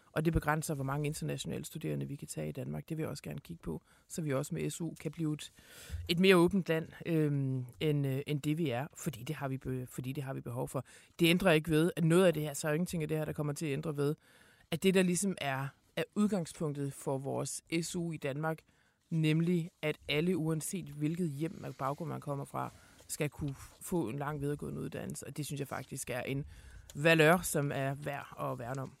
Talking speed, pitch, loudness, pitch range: 240 wpm, 150 Hz, -34 LUFS, 140-165 Hz